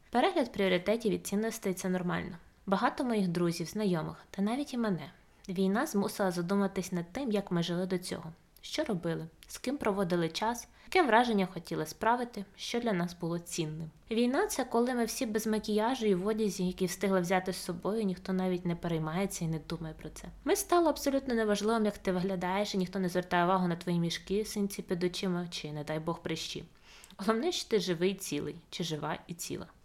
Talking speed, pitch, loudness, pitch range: 190 wpm, 190 Hz, -32 LUFS, 175-220 Hz